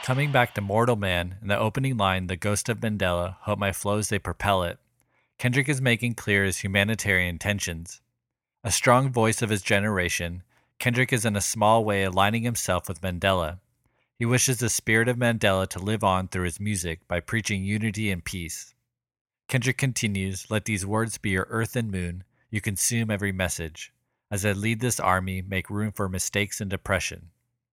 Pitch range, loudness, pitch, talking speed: 95-120 Hz, -25 LUFS, 105 Hz, 180 wpm